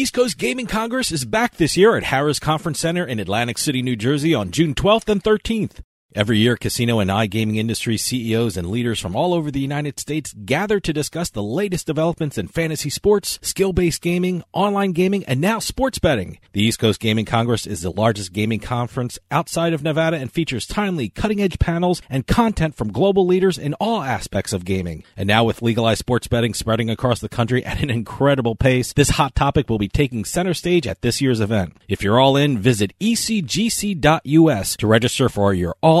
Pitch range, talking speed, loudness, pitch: 110-175 Hz, 200 wpm, -19 LUFS, 140 Hz